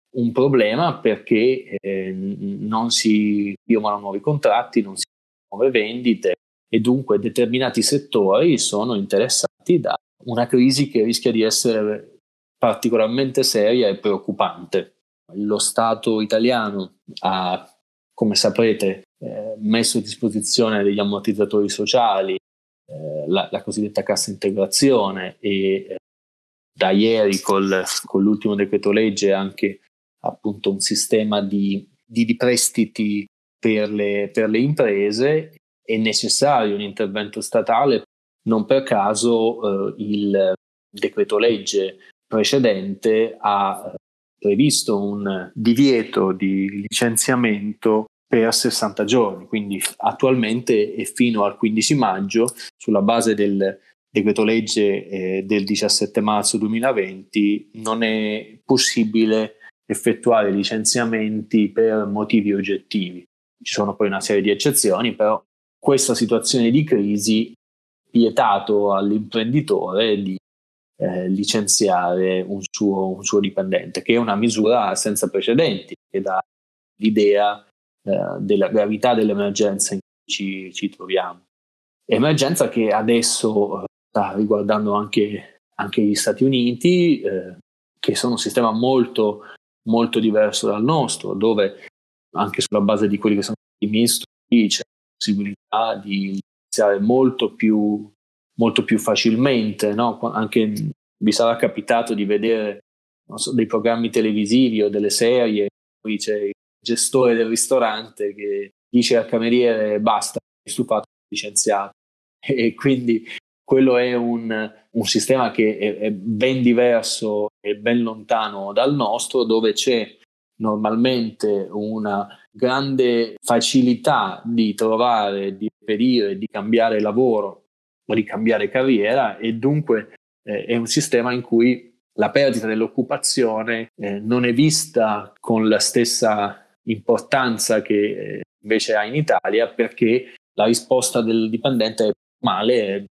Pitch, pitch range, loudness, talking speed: 110 Hz, 100-120 Hz, -19 LUFS, 125 wpm